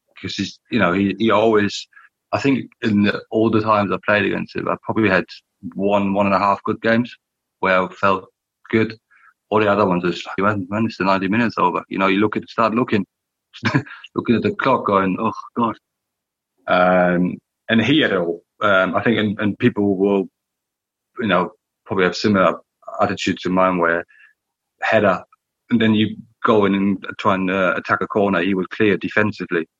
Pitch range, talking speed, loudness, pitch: 95-110 Hz, 195 wpm, -19 LUFS, 100 Hz